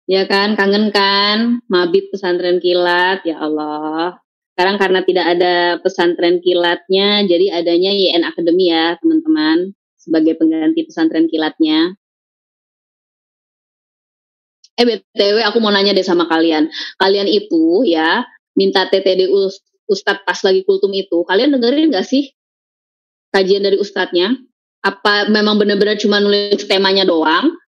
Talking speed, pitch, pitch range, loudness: 125 wpm, 195 Hz, 175-215 Hz, -14 LUFS